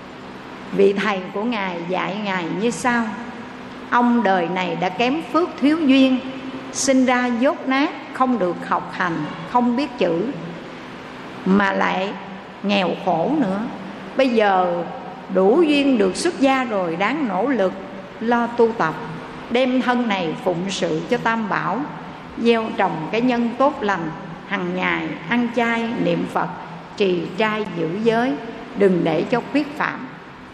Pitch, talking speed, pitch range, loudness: 225 Hz, 145 wpm, 185-250 Hz, -20 LUFS